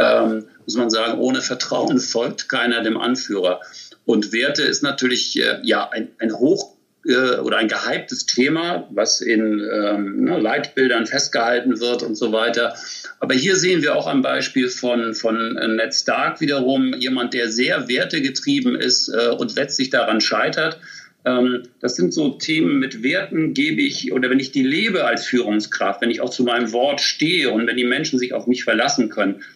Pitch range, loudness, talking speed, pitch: 115-135 Hz, -19 LUFS, 180 wpm, 125 Hz